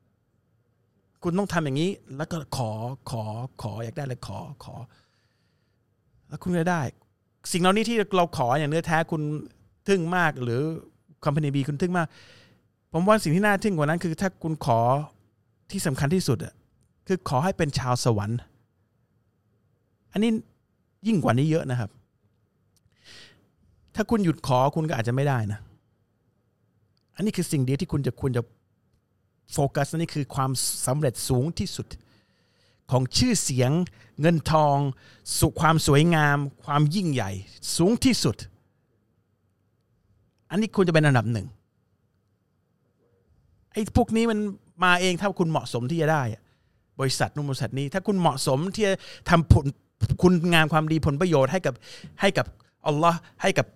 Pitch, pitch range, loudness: 140 Hz, 115-165 Hz, -25 LUFS